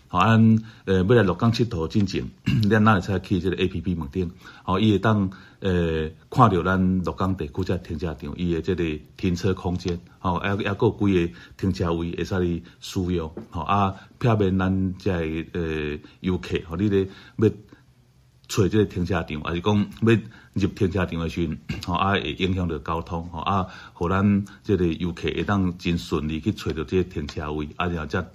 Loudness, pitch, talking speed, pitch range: -24 LUFS, 95 Hz, 275 characters per minute, 85-100 Hz